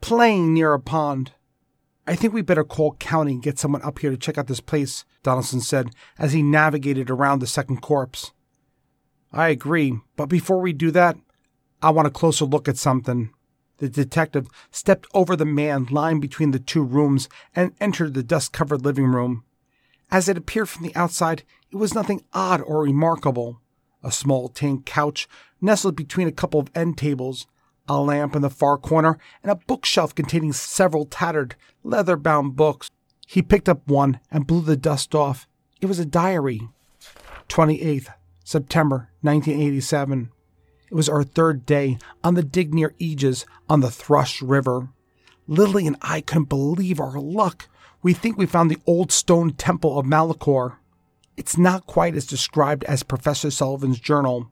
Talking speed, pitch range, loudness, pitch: 170 wpm, 135-165 Hz, -21 LUFS, 150 Hz